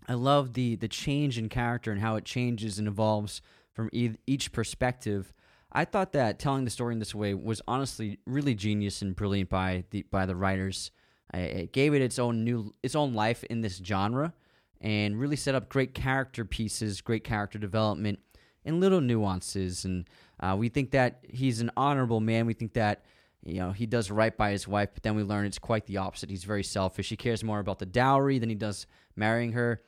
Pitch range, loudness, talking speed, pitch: 100-125 Hz, -30 LUFS, 210 wpm, 110 Hz